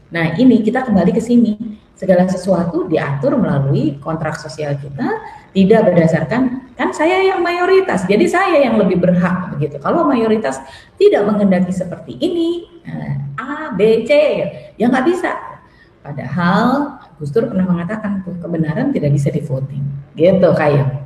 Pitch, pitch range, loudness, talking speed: 195 Hz, 160-255 Hz, -15 LUFS, 135 wpm